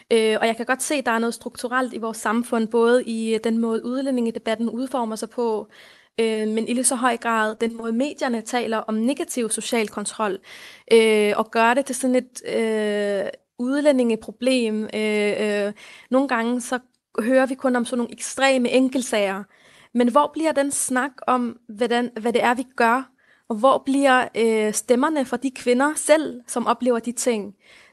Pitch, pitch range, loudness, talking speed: 240 Hz, 225-260 Hz, -22 LUFS, 180 wpm